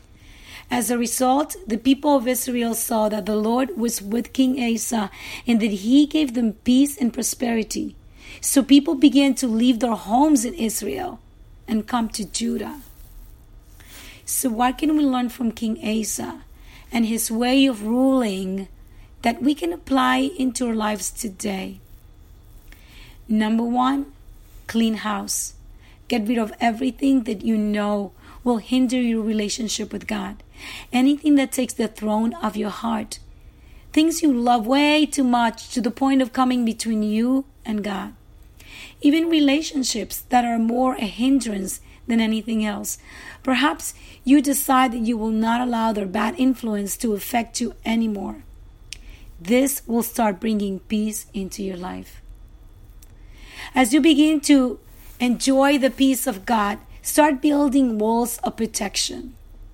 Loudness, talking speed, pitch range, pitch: -21 LUFS, 145 wpm, 215-260 Hz, 230 Hz